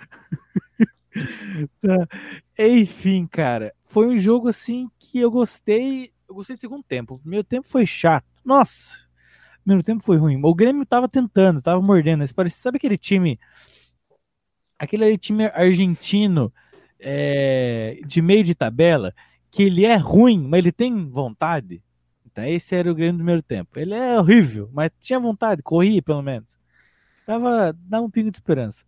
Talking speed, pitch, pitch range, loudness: 155 wpm, 190 Hz, 155-225 Hz, -19 LUFS